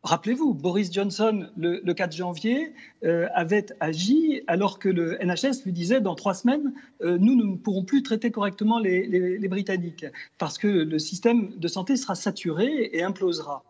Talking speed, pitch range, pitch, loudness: 175 wpm, 175-230 Hz, 195 Hz, -25 LUFS